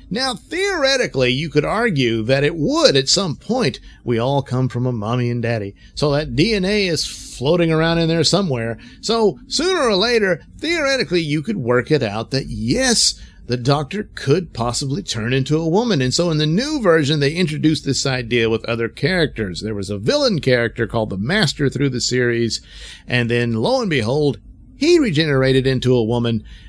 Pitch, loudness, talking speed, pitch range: 140 Hz, -18 LUFS, 185 wpm, 120-175 Hz